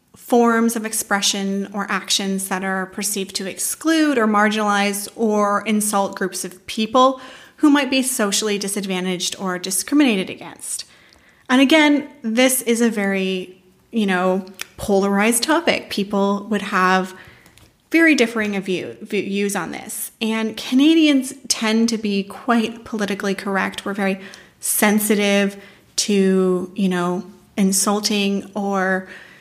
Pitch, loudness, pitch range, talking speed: 205 Hz, -19 LUFS, 195-230 Hz, 120 wpm